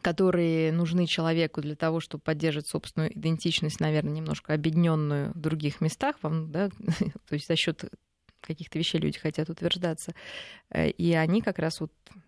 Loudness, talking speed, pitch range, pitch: -28 LUFS, 150 wpm, 155-170 Hz, 165 Hz